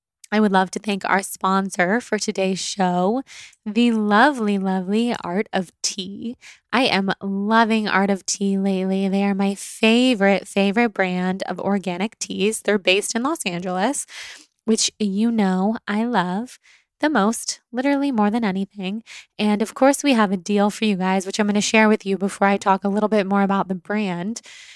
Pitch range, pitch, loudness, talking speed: 190-220 Hz, 205 Hz, -20 LUFS, 180 wpm